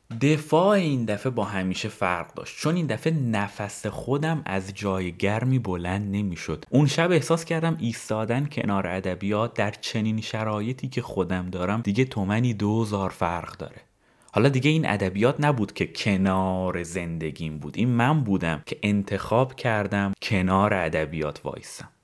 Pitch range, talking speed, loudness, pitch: 95-130 Hz, 145 wpm, -25 LUFS, 105 Hz